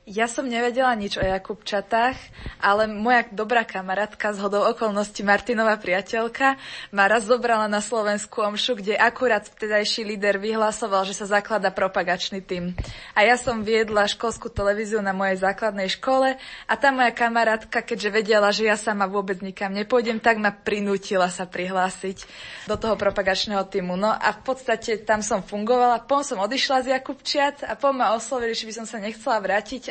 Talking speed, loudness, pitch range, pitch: 170 wpm, -23 LUFS, 200-235 Hz, 215 Hz